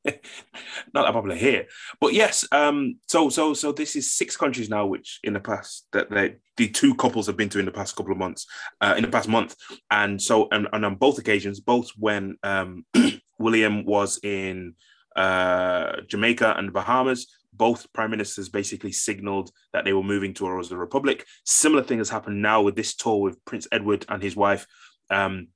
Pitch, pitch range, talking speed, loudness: 105 Hz, 100-130 Hz, 195 wpm, -23 LUFS